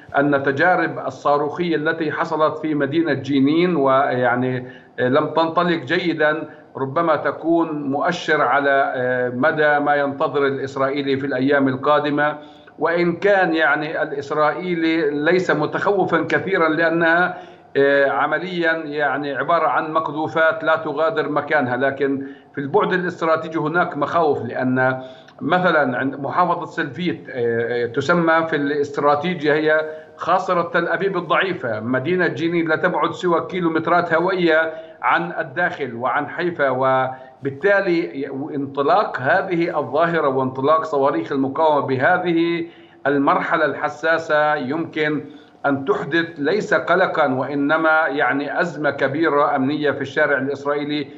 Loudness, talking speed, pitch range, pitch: -19 LUFS, 105 wpm, 140-165 Hz, 150 Hz